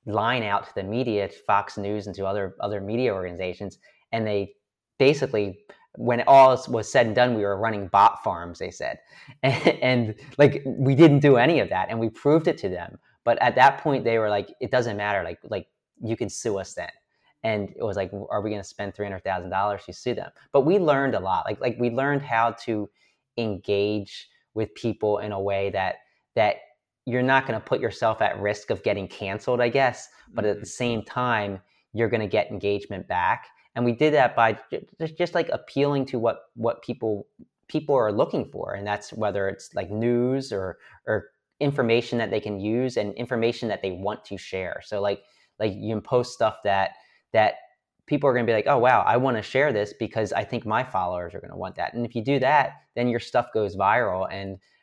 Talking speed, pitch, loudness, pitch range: 215 wpm, 110 Hz, -24 LUFS, 100-125 Hz